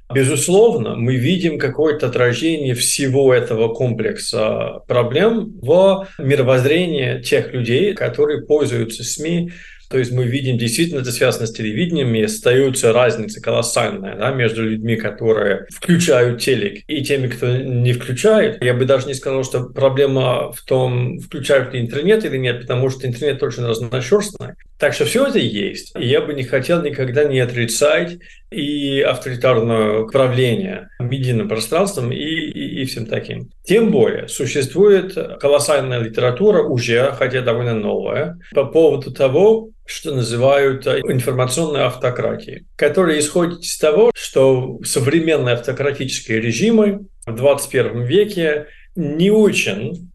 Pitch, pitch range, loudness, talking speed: 135 Hz, 125-160 Hz, -17 LUFS, 130 wpm